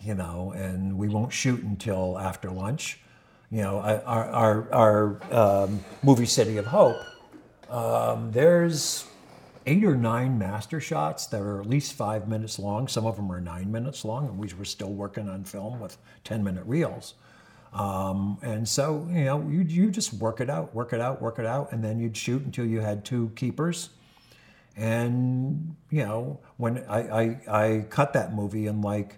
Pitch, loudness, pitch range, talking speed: 115 Hz, -27 LUFS, 105-135 Hz, 180 wpm